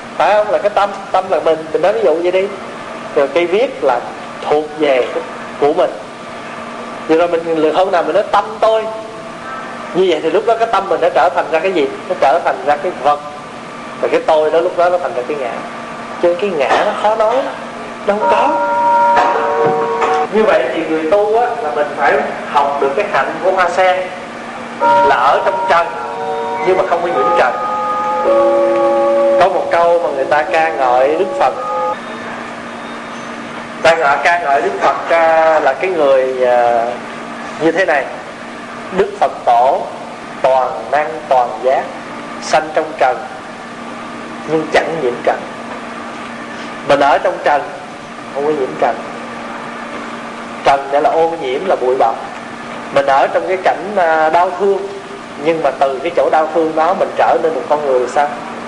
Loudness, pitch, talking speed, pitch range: -14 LUFS, 170 Hz, 175 wpm, 145-200 Hz